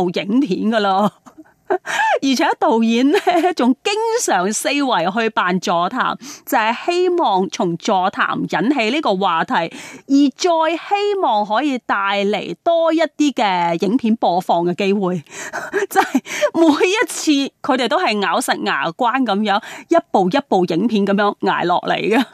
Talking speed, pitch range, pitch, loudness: 215 characters per minute, 205-335 Hz, 265 Hz, -17 LUFS